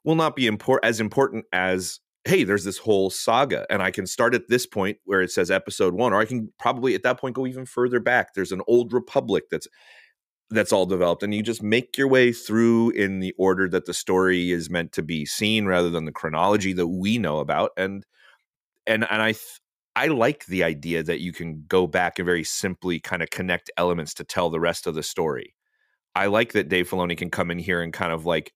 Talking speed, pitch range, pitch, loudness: 230 wpm, 90-115 Hz, 95 Hz, -23 LUFS